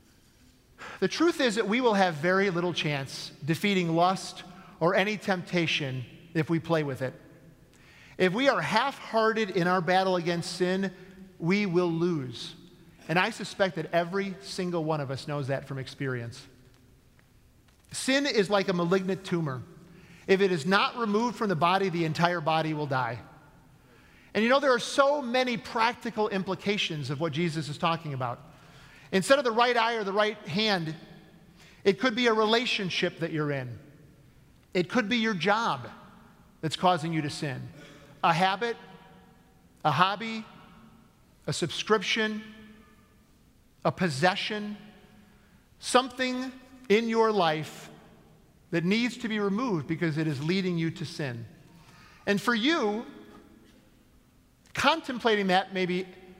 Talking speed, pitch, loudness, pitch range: 145 wpm, 185 Hz, -27 LUFS, 160-215 Hz